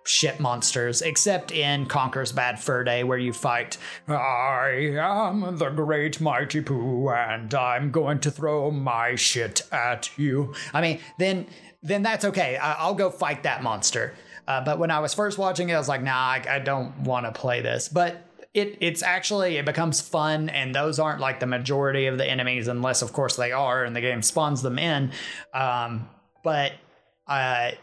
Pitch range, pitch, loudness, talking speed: 130-165 Hz, 145 Hz, -24 LUFS, 185 wpm